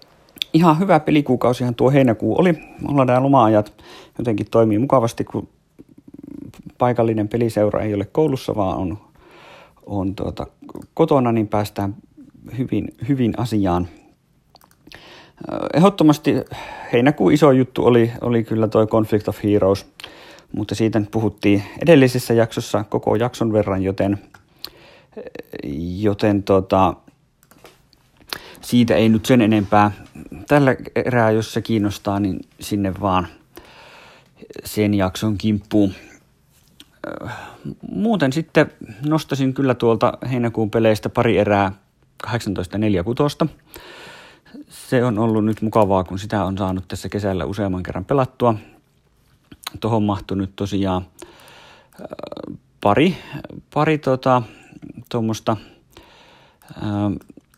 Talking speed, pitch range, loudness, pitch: 100 wpm, 100-125 Hz, -19 LUFS, 110 Hz